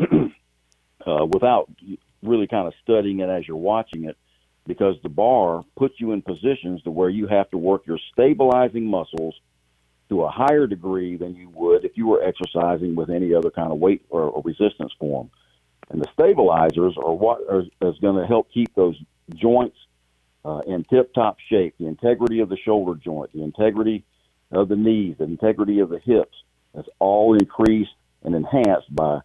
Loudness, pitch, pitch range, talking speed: -21 LUFS, 95 Hz, 80-110 Hz, 180 wpm